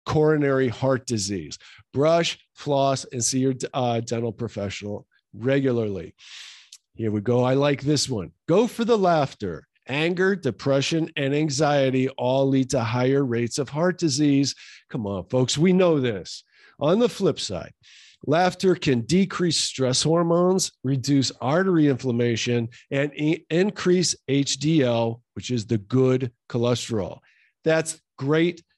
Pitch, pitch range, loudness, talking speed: 135 Hz, 120-160 Hz, -23 LUFS, 130 wpm